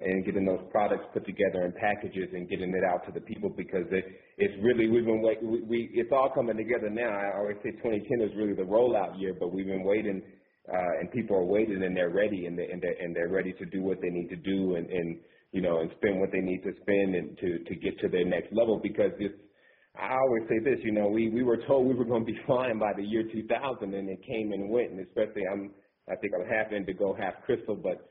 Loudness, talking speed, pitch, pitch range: -30 LUFS, 255 wpm, 100 Hz, 95-110 Hz